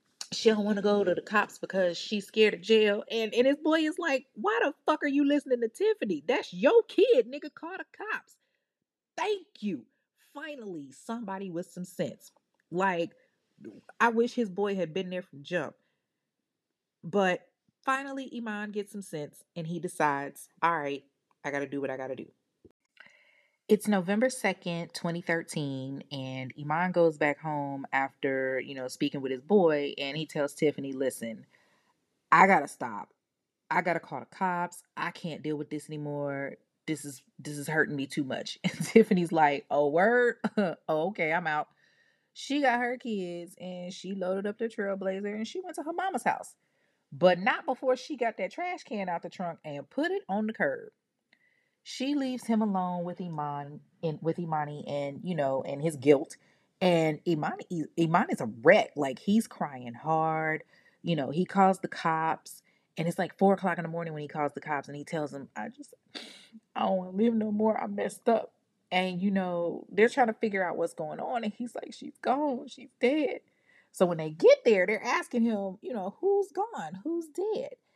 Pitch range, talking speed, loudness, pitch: 155-235 Hz, 190 wpm, -29 LUFS, 185 Hz